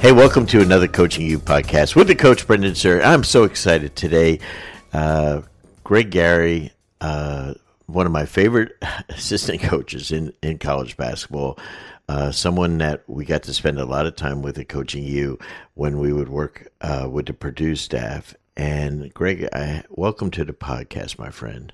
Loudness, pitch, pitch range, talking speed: -19 LUFS, 80 Hz, 70-90 Hz, 175 wpm